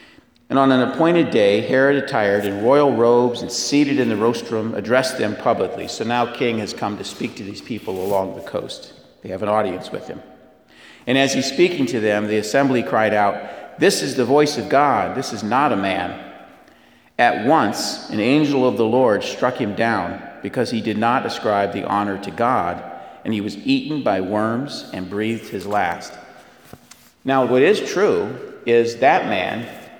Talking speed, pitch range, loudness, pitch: 190 wpm, 105-135 Hz, -19 LUFS, 115 Hz